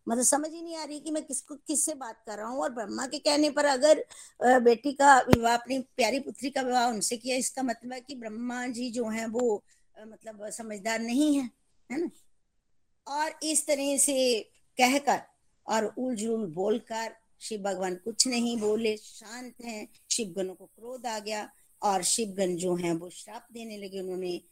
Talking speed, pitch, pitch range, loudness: 170 wpm, 235 Hz, 215-270 Hz, -28 LUFS